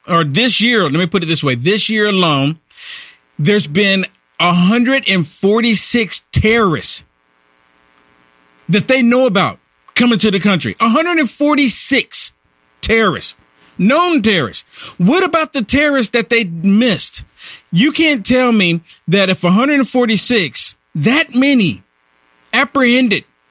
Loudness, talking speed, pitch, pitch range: -13 LUFS, 115 wpm, 200 Hz, 145-245 Hz